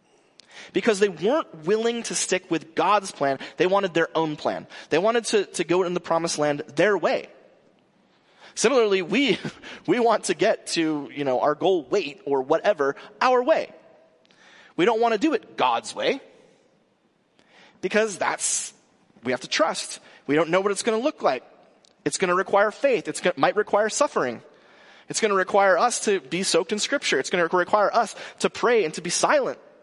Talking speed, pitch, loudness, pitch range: 190 wpm, 200 Hz, -23 LUFS, 165-235 Hz